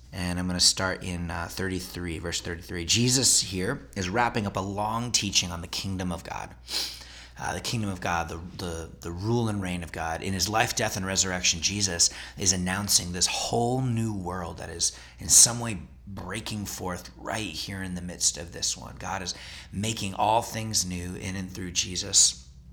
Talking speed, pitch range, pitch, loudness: 195 wpm, 85-100 Hz, 90 Hz, -26 LUFS